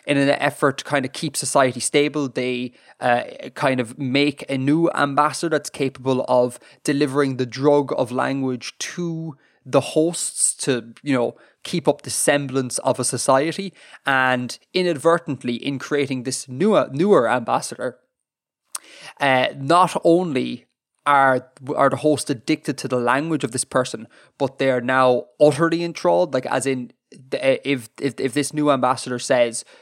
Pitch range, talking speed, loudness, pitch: 130-150 Hz, 155 wpm, -21 LUFS, 140 Hz